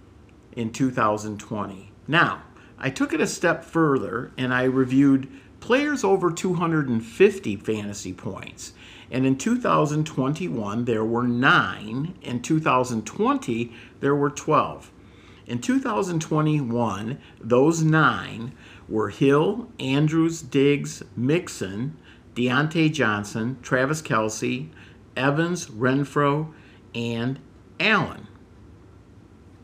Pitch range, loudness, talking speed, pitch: 110-155 Hz, -23 LUFS, 90 wpm, 125 Hz